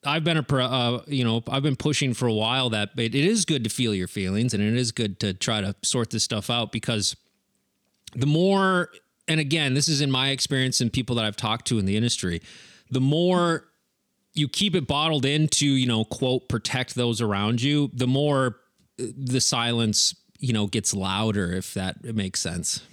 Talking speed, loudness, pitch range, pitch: 205 wpm, -24 LUFS, 110-140 Hz, 125 Hz